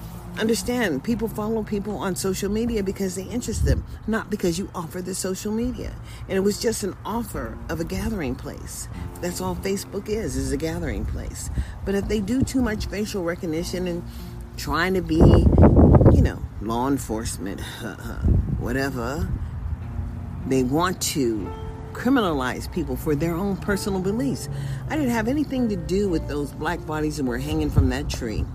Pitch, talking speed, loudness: 165 Hz, 165 wpm, -24 LUFS